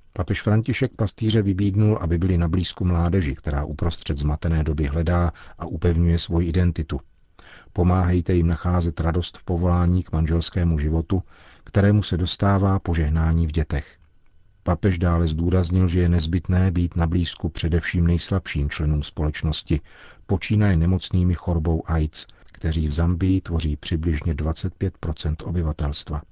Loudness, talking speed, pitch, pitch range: -22 LUFS, 130 wpm, 85 Hz, 80-90 Hz